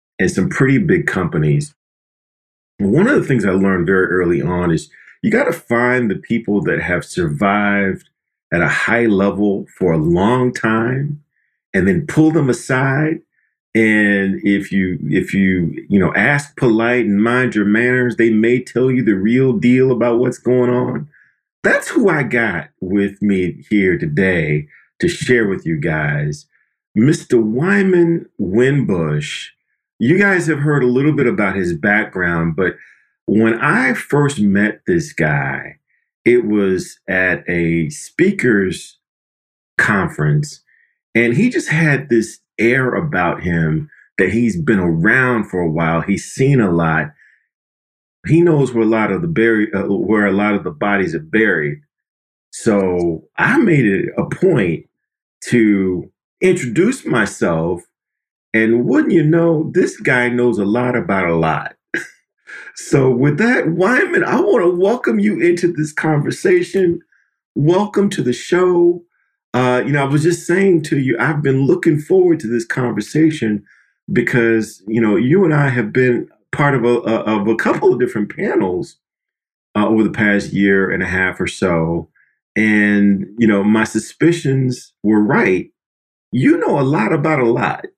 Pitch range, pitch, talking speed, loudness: 100-150 Hz, 115 Hz, 160 wpm, -15 LUFS